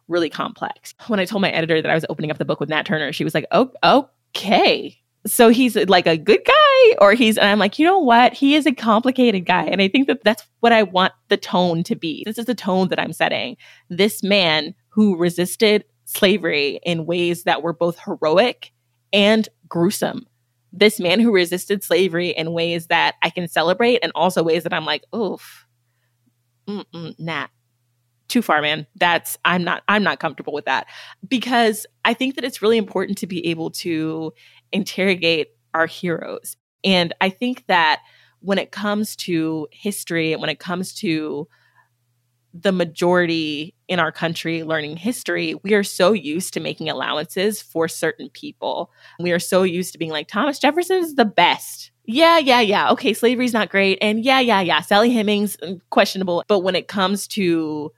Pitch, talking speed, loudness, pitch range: 180 Hz, 185 wpm, -18 LUFS, 160-210 Hz